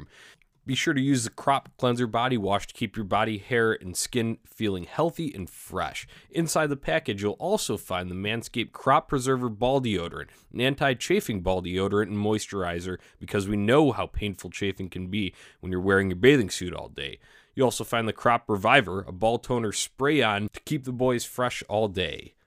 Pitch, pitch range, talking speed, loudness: 110 Hz, 95-130 Hz, 190 wpm, -26 LUFS